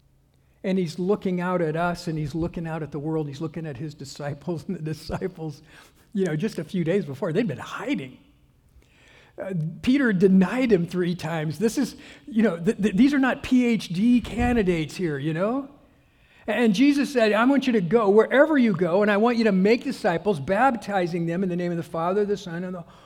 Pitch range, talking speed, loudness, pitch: 165-225 Hz, 215 wpm, -23 LUFS, 190 Hz